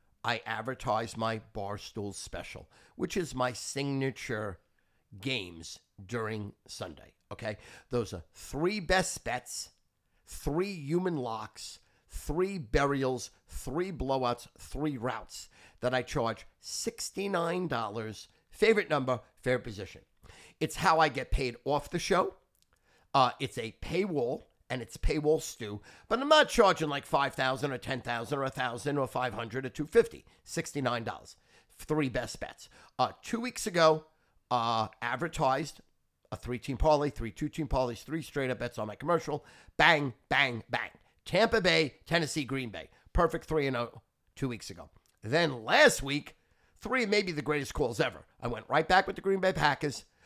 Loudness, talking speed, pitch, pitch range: -31 LUFS, 150 wpm, 130 Hz, 115-155 Hz